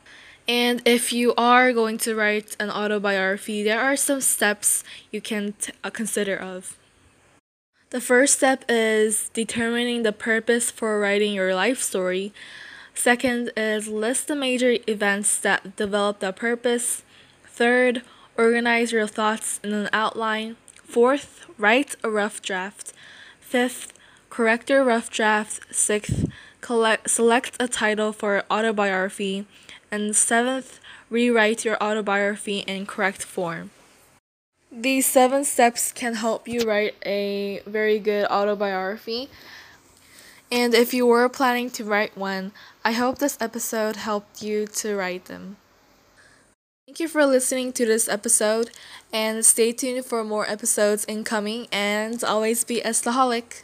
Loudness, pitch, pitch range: -22 LUFS, 220 Hz, 210-240 Hz